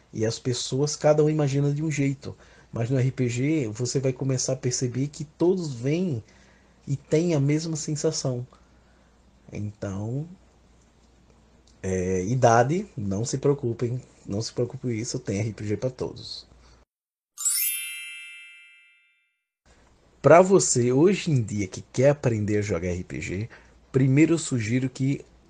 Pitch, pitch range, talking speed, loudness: 130 Hz, 105-140 Hz, 130 wpm, -25 LUFS